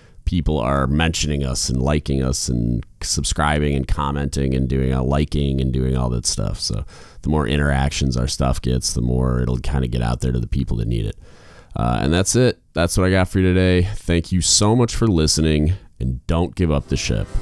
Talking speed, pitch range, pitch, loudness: 220 wpm, 65-85 Hz, 70 Hz, -20 LUFS